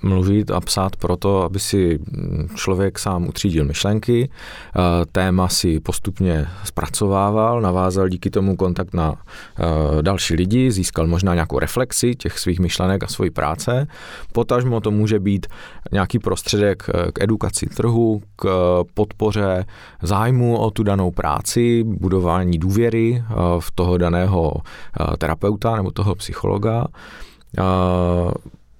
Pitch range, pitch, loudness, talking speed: 90-110 Hz, 95 Hz, -19 LUFS, 115 wpm